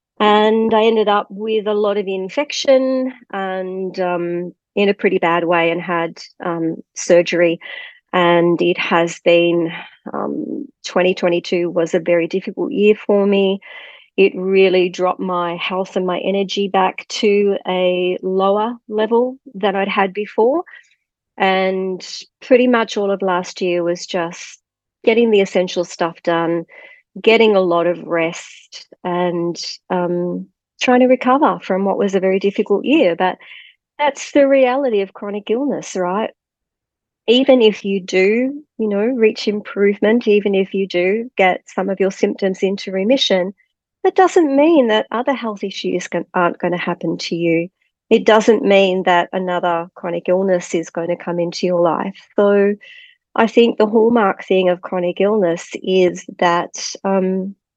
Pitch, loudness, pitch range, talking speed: 195 Hz, -17 LUFS, 180-220 Hz, 155 wpm